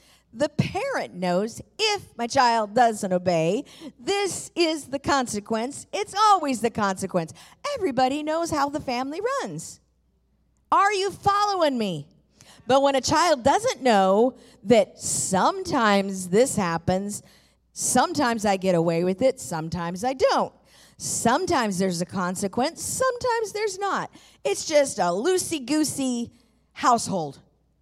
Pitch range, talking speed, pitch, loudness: 200-320 Hz, 125 wpm, 255 Hz, -24 LUFS